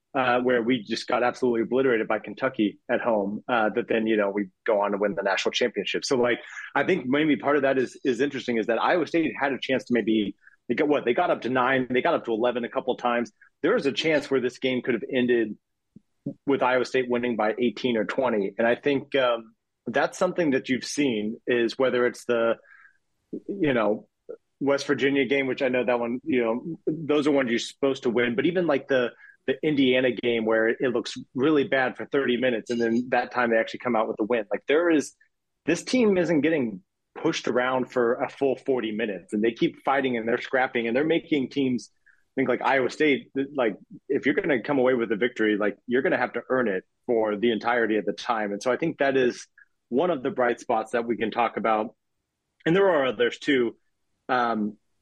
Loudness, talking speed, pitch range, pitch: -25 LUFS, 230 wpm, 115-135 Hz, 125 Hz